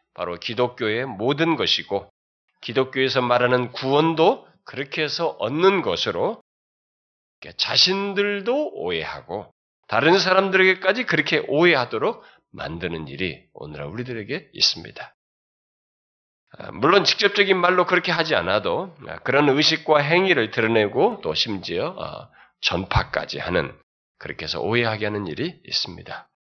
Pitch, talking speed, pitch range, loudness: 145 Hz, 290 characters per minute, 115-185 Hz, -21 LUFS